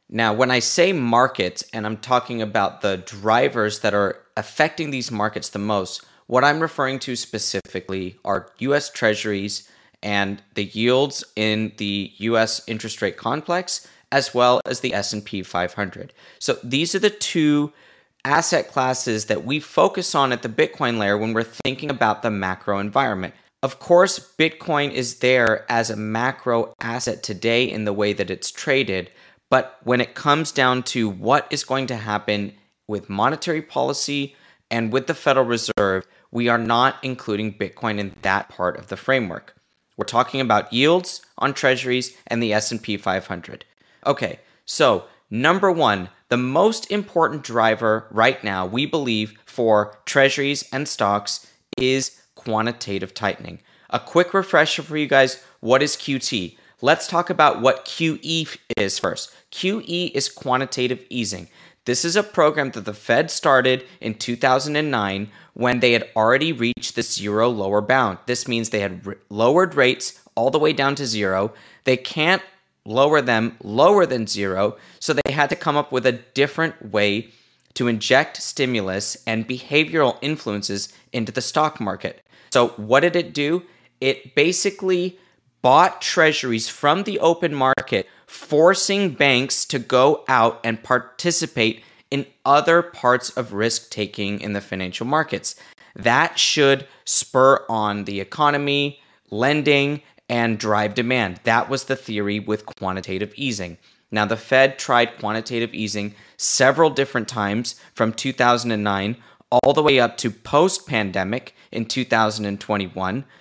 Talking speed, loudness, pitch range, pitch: 150 wpm, -20 LUFS, 105-140 Hz, 120 Hz